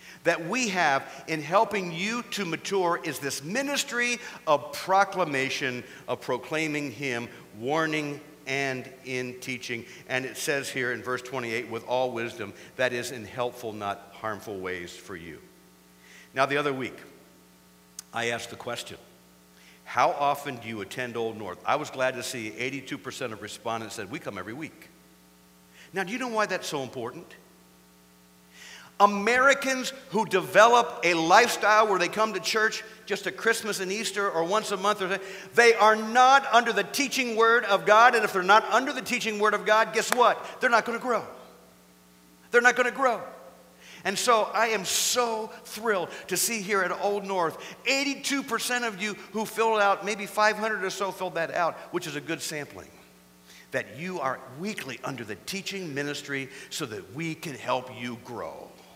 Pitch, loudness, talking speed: 165 Hz, -26 LUFS, 175 wpm